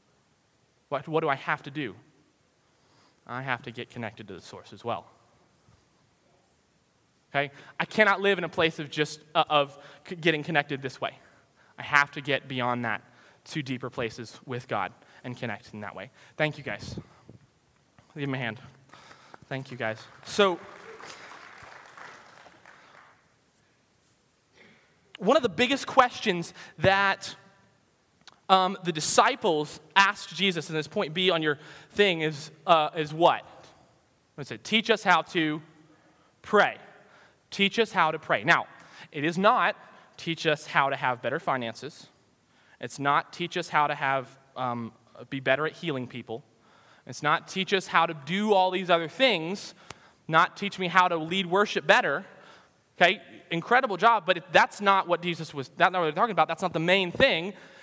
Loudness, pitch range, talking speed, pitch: -26 LUFS, 135-185 Hz, 165 wpm, 155 Hz